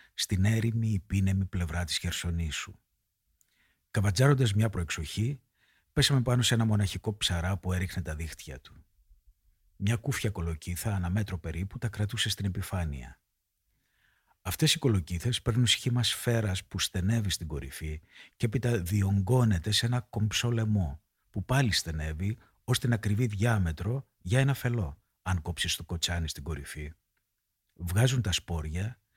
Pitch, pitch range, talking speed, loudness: 100 Hz, 85-115 Hz, 135 wpm, -30 LUFS